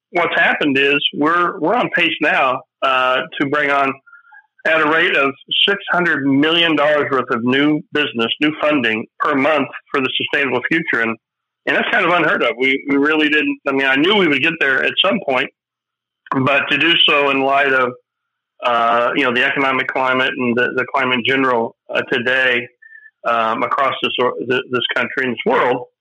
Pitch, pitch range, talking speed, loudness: 140 Hz, 130-155 Hz, 195 wpm, -15 LUFS